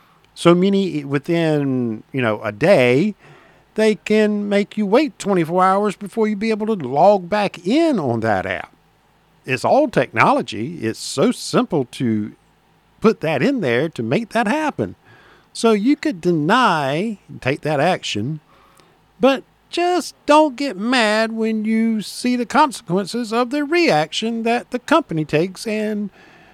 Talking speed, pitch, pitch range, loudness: 145 wpm, 210 Hz, 160-230 Hz, -18 LUFS